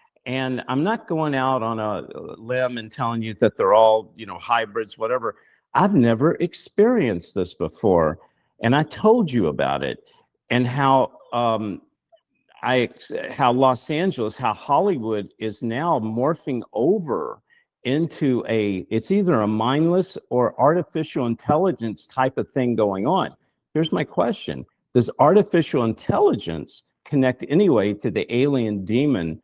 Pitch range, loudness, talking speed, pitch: 115-170 Hz, -21 LUFS, 135 wpm, 130 Hz